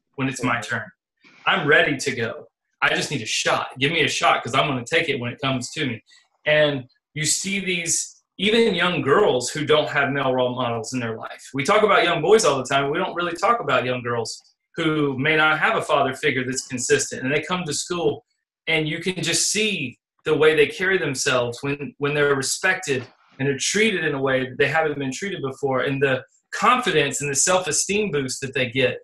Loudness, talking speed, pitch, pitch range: -21 LUFS, 230 wpm, 145 Hz, 130-165 Hz